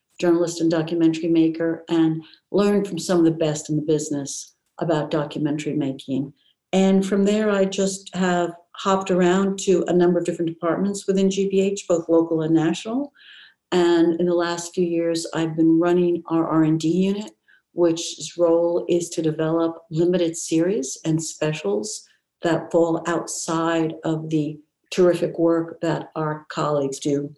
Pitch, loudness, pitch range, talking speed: 165 Hz, -22 LUFS, 160-180 Hz, 150 wpm